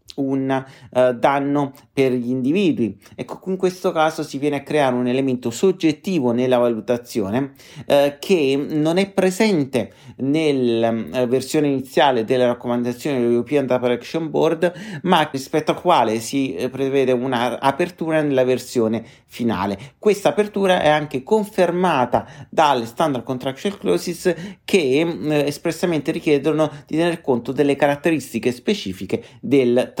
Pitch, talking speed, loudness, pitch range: 140 Hz, 130 wpm, -20 LUFS, 125-165 Hz